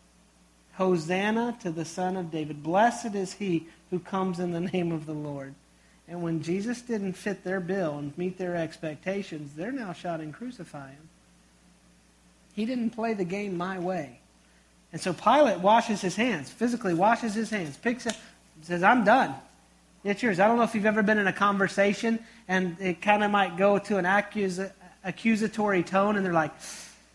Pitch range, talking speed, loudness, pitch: 165-210 Hz, 175 wpm, -27 LUFS, 185 Hz